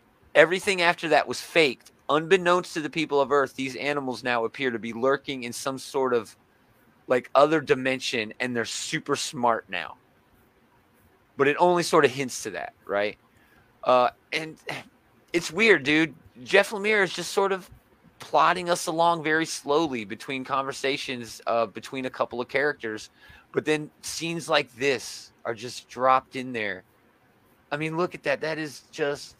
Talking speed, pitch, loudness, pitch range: 165 wpm, 140 Hz, -25 LUFS, 120-160 Hz